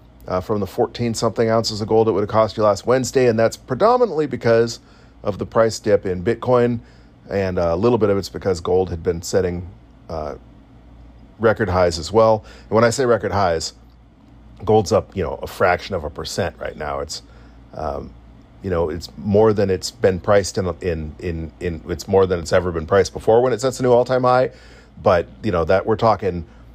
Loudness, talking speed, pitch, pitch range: -19 LUFS, 210 wpm, 105 Hz, 90-115 Hz